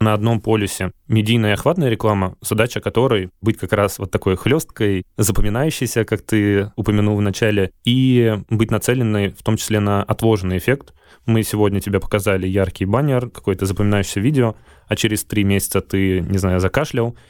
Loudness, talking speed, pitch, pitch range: -18 LUFS, 165 wpm, 105 Hz, 100-115 Hz